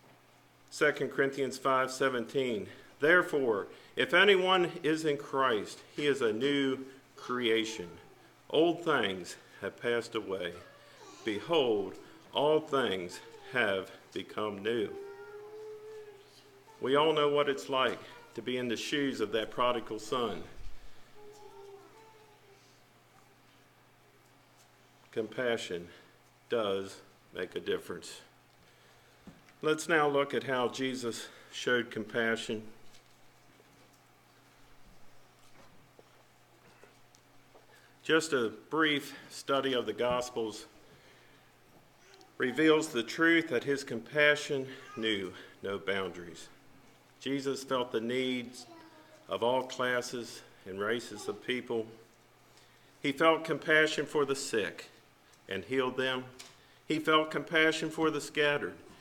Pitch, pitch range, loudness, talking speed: 135 Hz, 120-155 Hz, -31 LUFS, 95 wpm